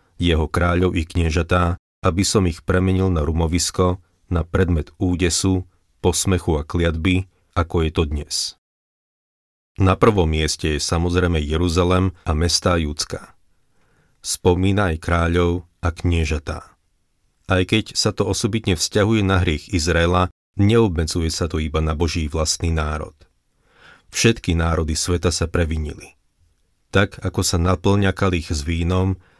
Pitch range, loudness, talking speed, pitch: 80-95 Hz, -20 LUFS, 130 wpm, 90 Hz